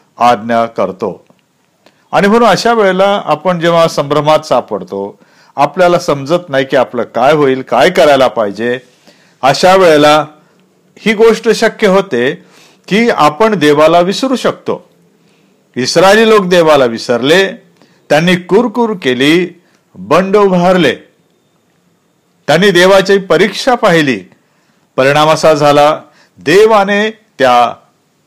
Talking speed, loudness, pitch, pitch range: 105 wpm, -9 LUFS, 175 Hz, 145-200 Hz